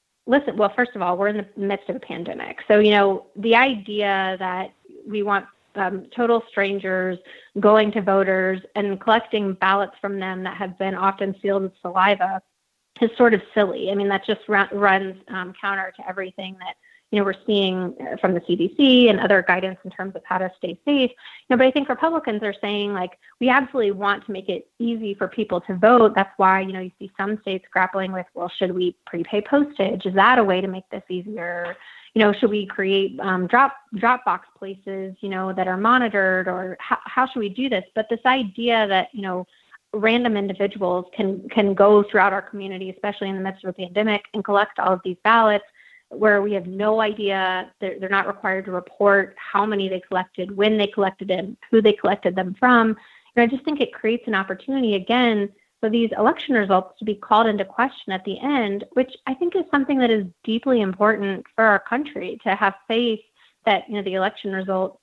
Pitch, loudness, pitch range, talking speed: 200 Hz, -21 LUFS, 190-225 Hz, 210 wpm